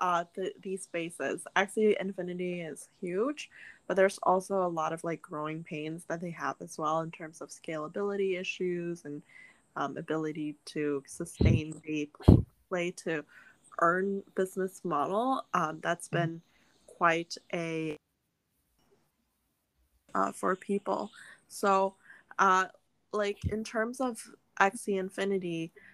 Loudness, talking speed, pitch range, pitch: -32 LUFS, 125 wpm, 155-195 Hz, 175 Hz